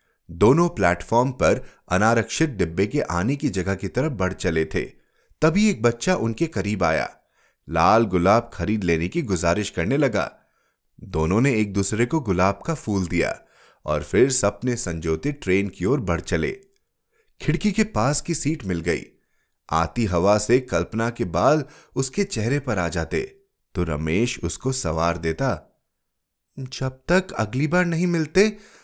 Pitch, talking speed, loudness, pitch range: 115 Hz, 155 wpm, -22 LUFS, 90-150 Hz